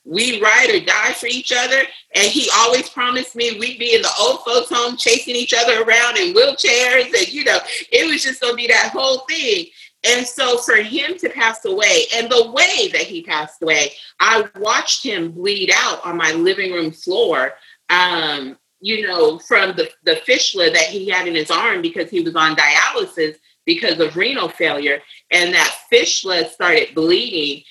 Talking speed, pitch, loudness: 190 wpm, 240 Hz, -15 LUFS